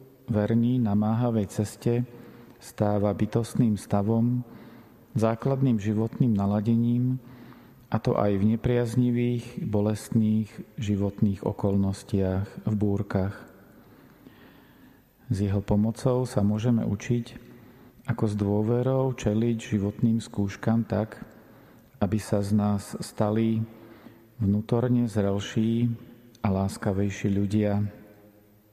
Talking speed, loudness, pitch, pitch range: 90 wpm, -26 LUFS, 110 Hz, 105-120 Hz